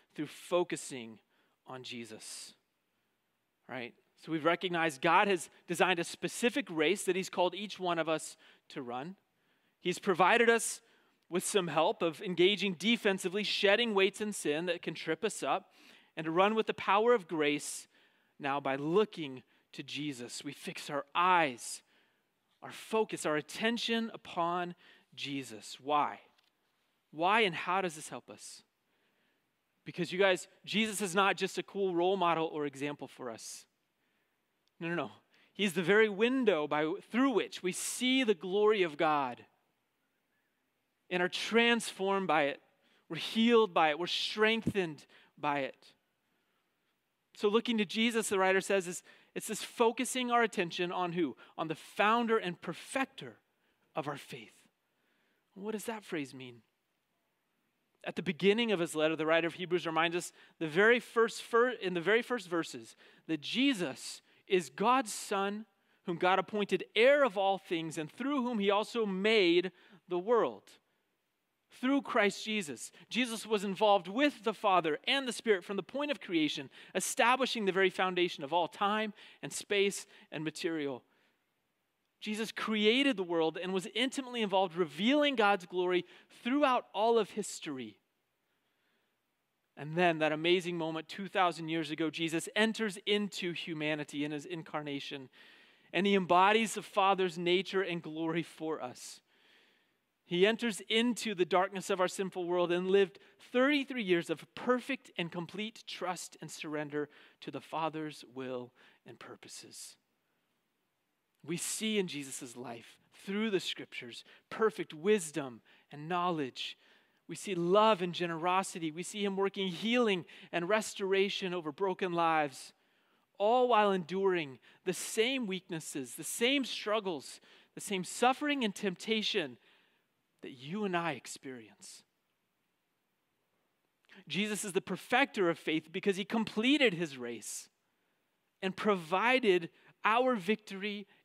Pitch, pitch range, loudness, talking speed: 190 Hz, 165-215 Hz, -32 LUFS, 145 wpm